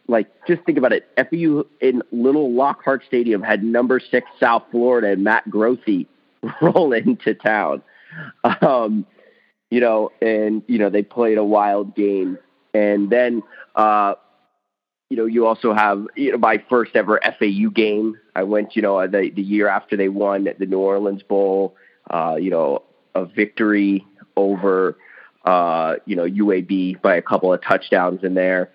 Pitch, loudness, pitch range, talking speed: 105 Hz, -19 LUFS, 100-120 Hz, 165 wpm